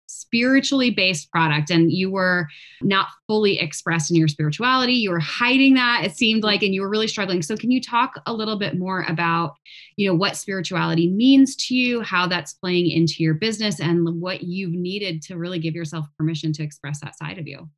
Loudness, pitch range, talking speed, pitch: -20 LUFS, 165-215 Hz, 205 wpm, 180 Hz